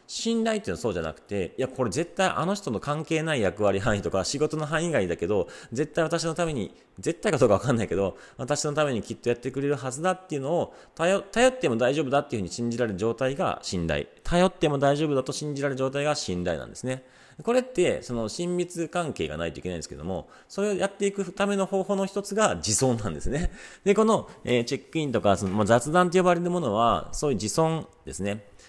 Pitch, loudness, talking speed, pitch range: 150 Hz, -26 LUFS, 460 characters per minute, 120-180 Hz